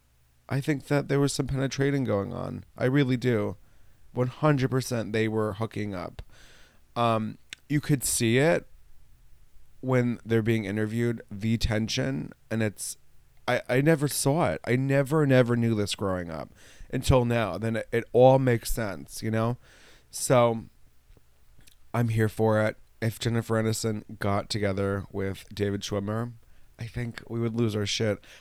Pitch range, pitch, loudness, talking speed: 105-125 Hz, 115 Hz, -27 LUFS, 150 wpm